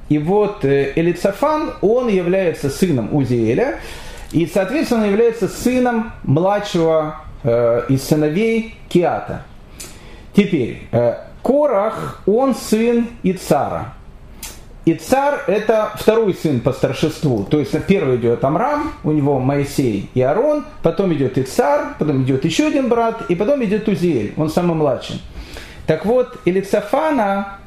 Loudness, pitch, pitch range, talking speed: -17 LUFS, 185 Hz, 150-230 Hz, 125 wpm